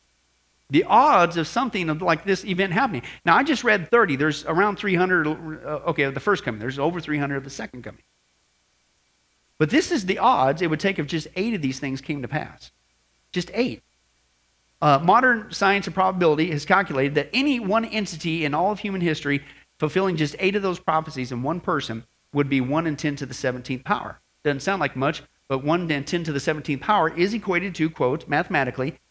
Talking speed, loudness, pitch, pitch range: 200 wpm, -23 LUFS, 155 Hz, 135-190 Hz